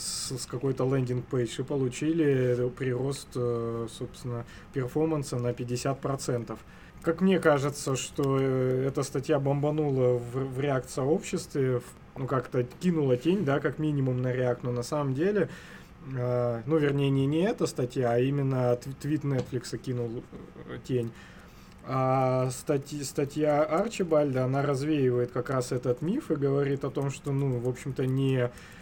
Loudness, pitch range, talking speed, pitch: -29 LUFS, 125-145 Hz, 130 wpm, 135 Hz